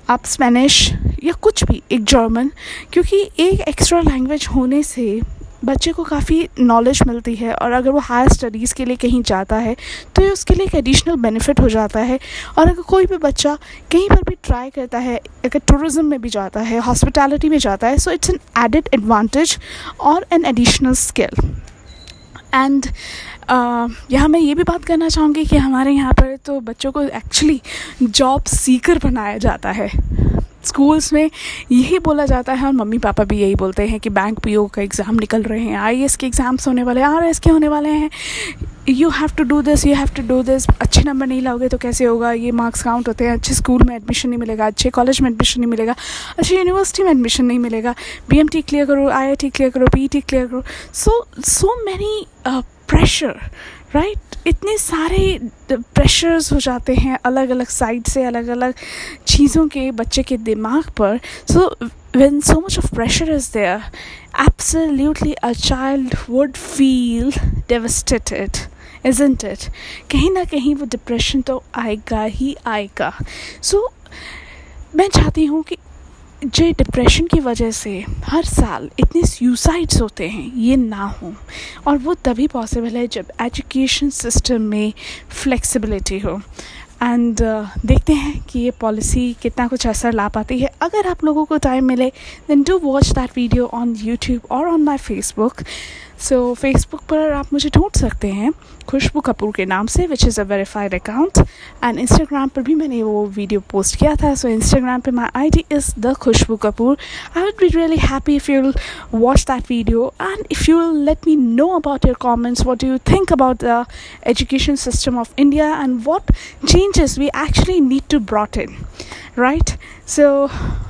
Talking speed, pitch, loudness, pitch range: 175 wpm, 265 Hz, -16 LUFS, 235-300 Hz